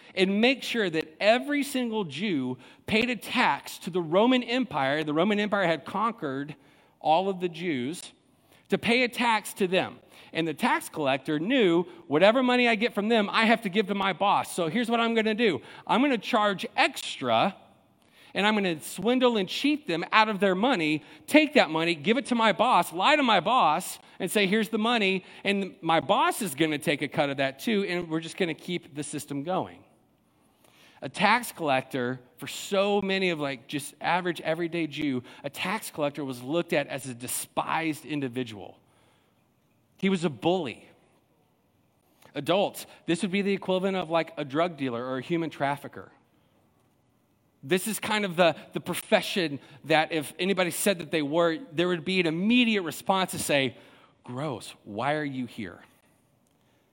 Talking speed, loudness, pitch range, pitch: 180 wpm, -26 LUFS, 150-215 Hz, 180 Hz